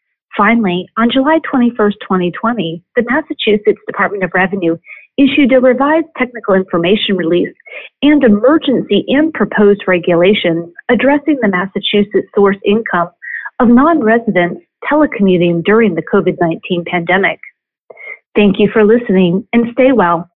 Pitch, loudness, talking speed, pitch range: 210 Hz, -12 LUFS, 120 wpm, 185-255 Hz